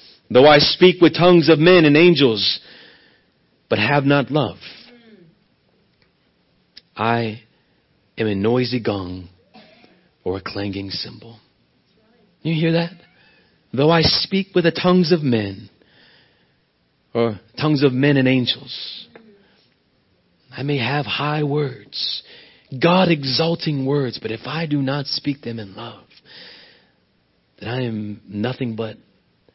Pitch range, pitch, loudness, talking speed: 115-165 Hz, 135 Hz, -18 LUFS, 125 wpm